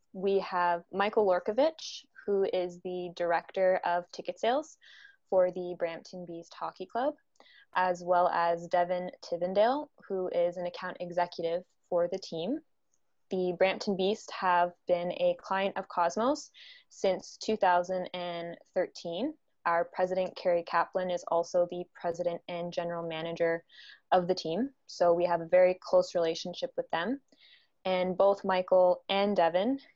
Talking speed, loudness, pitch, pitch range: 140 wpm, -31 LUFS, 180 Hz, 175-200 Hz